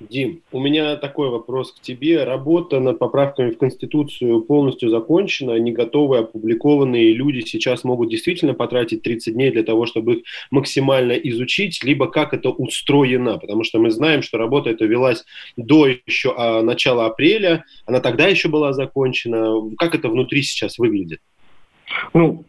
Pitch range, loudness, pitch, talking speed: 120-150 Hz, -18 LUFS, 135 Hz, 155 wpm